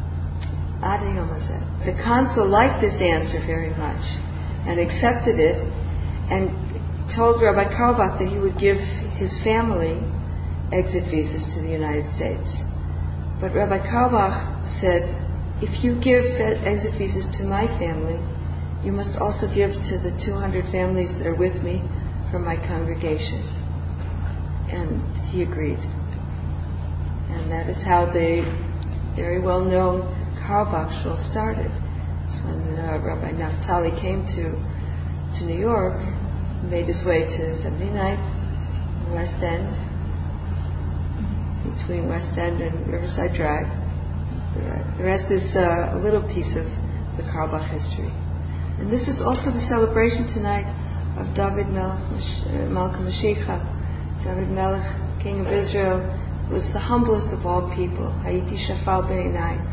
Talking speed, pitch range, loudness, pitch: 125 wpm, 80-90 Hz, -24 LUFS, 85 Hz